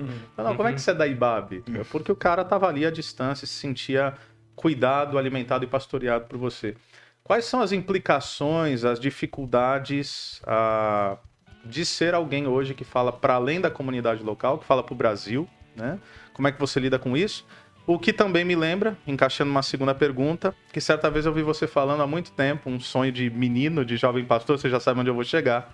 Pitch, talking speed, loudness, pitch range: 135 Hz, 210 wpm, -25 LUFS, 125-155 Hz